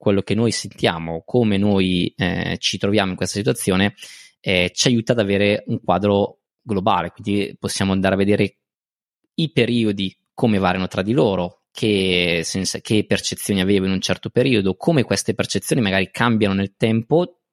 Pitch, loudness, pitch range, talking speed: 100 Hz, -20 LUFS, 95-110 Hz, 165 wpm